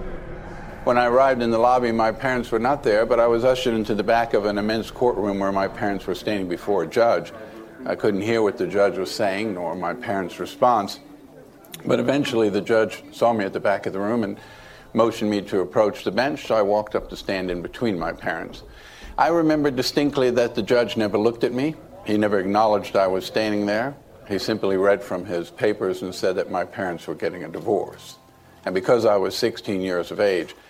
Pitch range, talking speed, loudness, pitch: 100-120 Hz, 215 wpm, -22 LUFS, 110 Hz